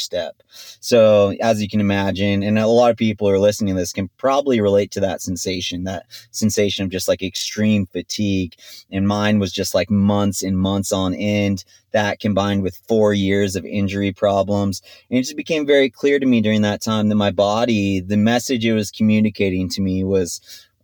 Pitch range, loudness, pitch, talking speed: 95-110 Hz, -18 LUFS, 100 Hz, 200 wpm